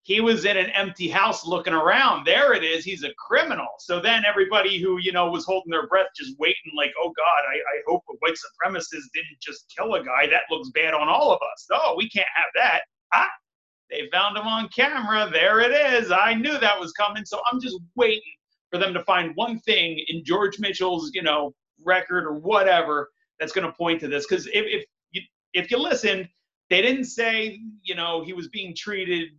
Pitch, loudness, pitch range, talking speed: 195 Hz, -22 LUFS, 175-225 Hz, 215 wpm